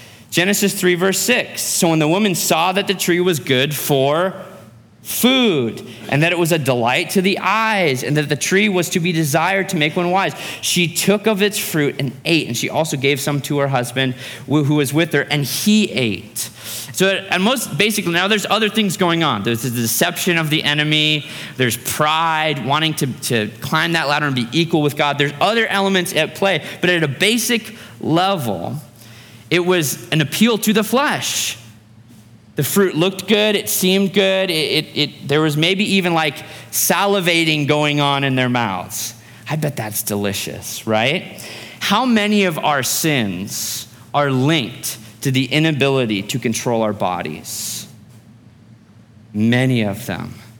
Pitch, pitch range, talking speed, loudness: 150 Hz, 120-185 Hz, 175 wpm, -17 LUFS